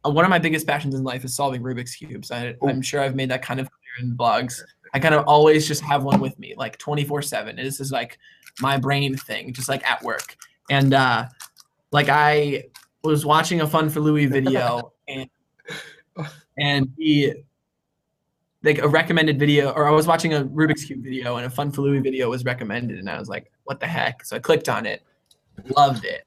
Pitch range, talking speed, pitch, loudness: 130-150 Hz, 210 wpm, 140 Hz, -21 LUFS